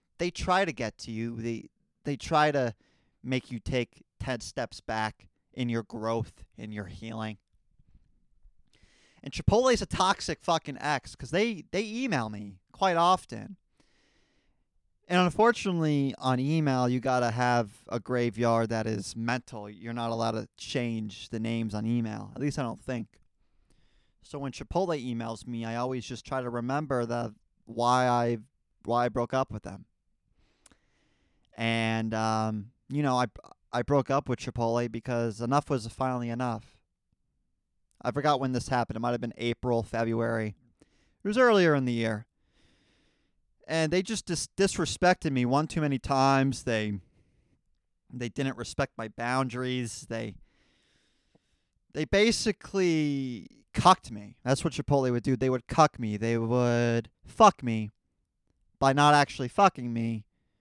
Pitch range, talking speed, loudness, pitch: 115-140 Hz, 150 wpm, -29 LUFS, 120 Hz